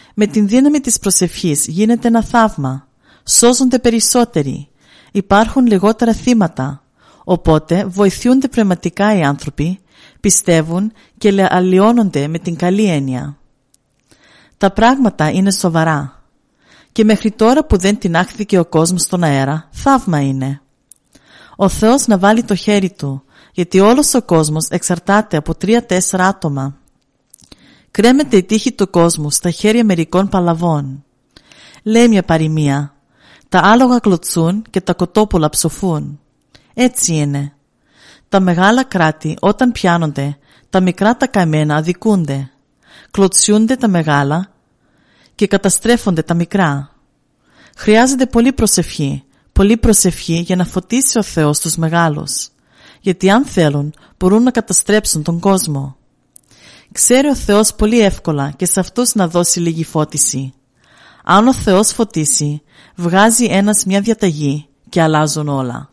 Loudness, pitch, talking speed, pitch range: -13 LUFS, 180 Hz, 125 wpm, 155-215 Hz